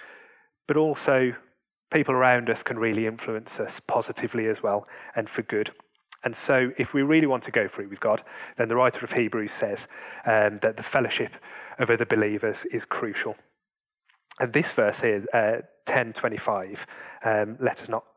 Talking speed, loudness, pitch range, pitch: 170 wpm, -26 LUFS, 110-155 Hz, 125 Hz